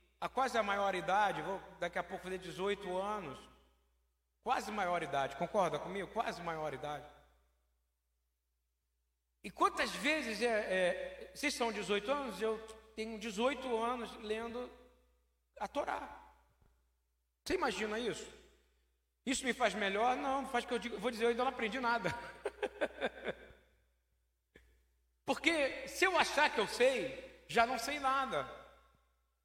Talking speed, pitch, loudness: 130 wpm, 195 Hz, -36 LUFS